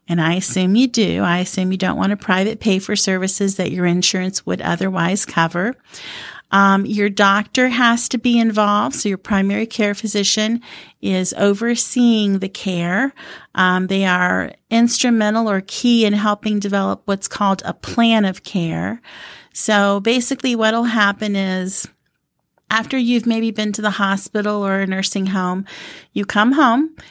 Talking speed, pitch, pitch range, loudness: 155 wpm, 205 Hz, 190-225 Hz, -17 LUFS